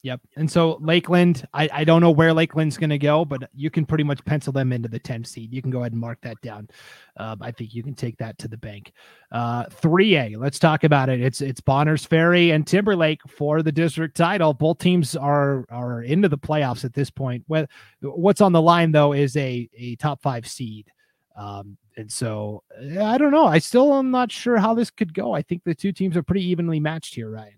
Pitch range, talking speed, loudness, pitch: 125-165 Hz, 230 wpm, -20 LUFS, 150 Hz